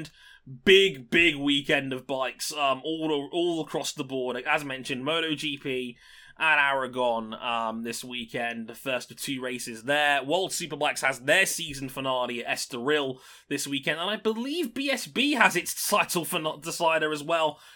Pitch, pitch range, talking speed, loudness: 145 Hz, 130-165 Hz, 160 wpm, -26 LUFS